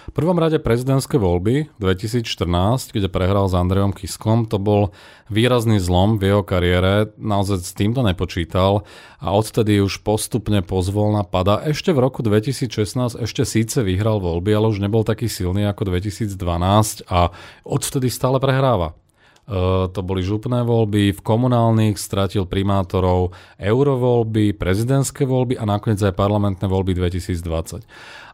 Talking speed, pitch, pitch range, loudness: 140 wpm, 105 Hz, 95-115 Hz, -19 LUFS